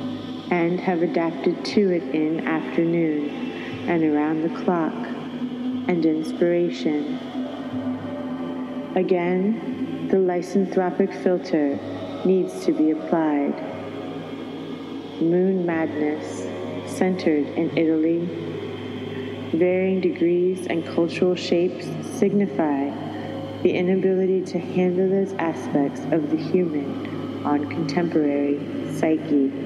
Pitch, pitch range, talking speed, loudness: 175 Hz, 155-190 Hz, 90 wpm, -23 LUFS